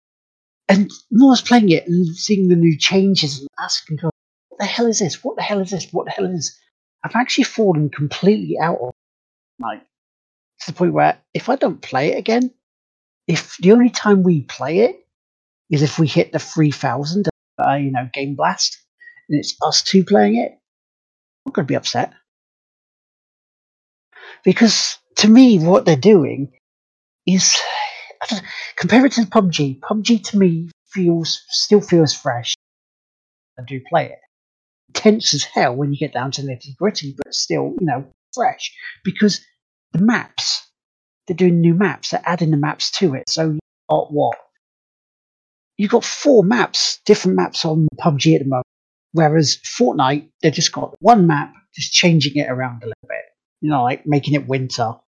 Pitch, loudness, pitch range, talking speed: 165 Hz, -17 LUFS, 140-200 Hz, 175 wpm